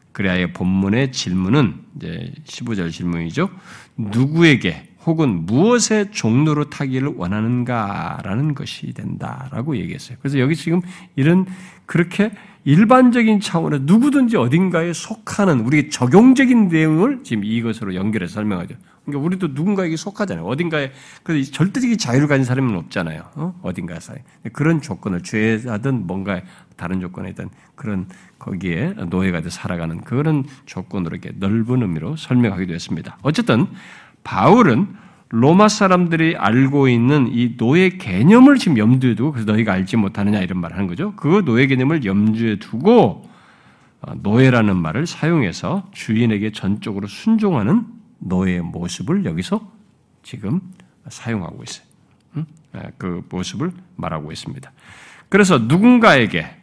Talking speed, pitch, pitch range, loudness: 340 characters per minute, 140 Hz, 110-180 Hz, -17 LUFS